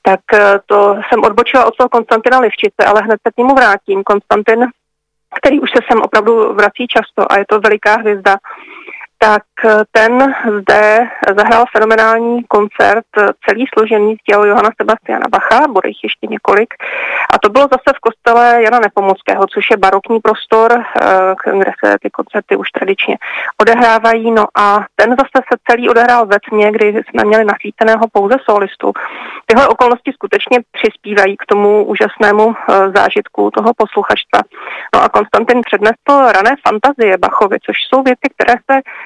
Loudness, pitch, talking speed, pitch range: -10 LUFS, 225 Hz, 150 wpm, 210-245 Hz